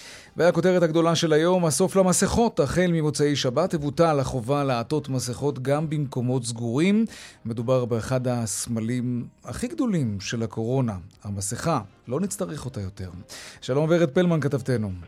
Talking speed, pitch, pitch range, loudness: 125 wpm, 135 Hz, 120-165 Hz, -24 LUFS